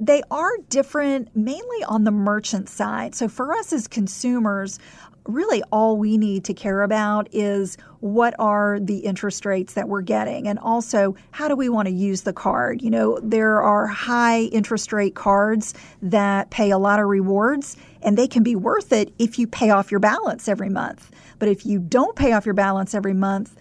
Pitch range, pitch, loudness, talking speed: 200-235 Hz, 210 Hz, -21 LUFS, 195 wpm